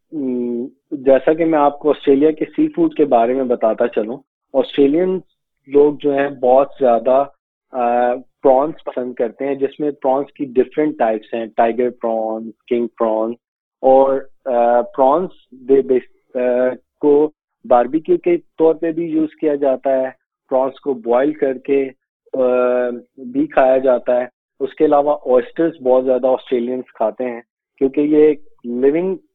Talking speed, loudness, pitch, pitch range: 140 wpm, -17 LUFS, 135 Hz, 125-155 Hz